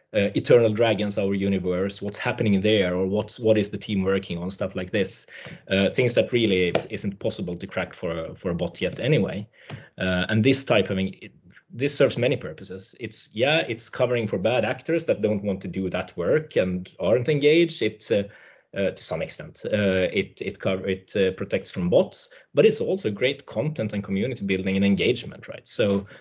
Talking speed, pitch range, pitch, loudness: 200 wpm, 95-110 Hz, 100 Hz, -24 LUFS